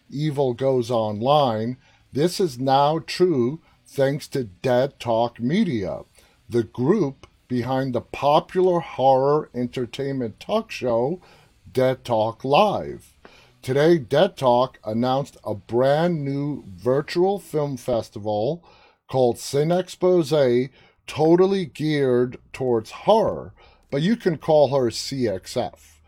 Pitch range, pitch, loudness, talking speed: 120-155 Hz, 135 Hz, -22 LUFS, 105 wpm